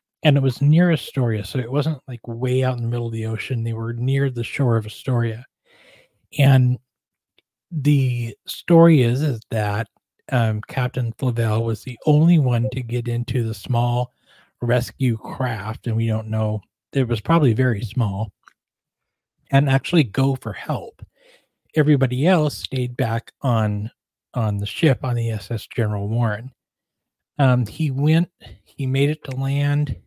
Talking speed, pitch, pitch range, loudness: 160 wpm, 125 Hz, 115-140 Hz, -21 LUFS